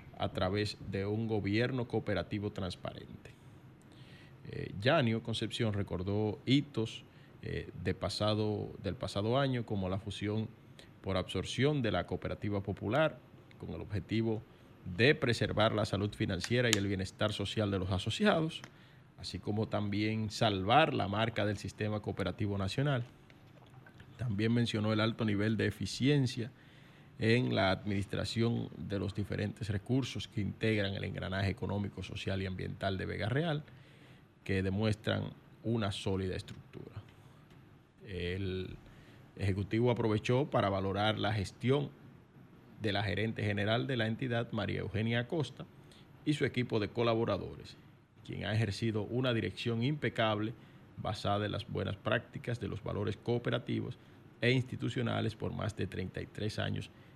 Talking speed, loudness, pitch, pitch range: 130 wpm, -34 LUFS, 110 Hz, 100-120 Hz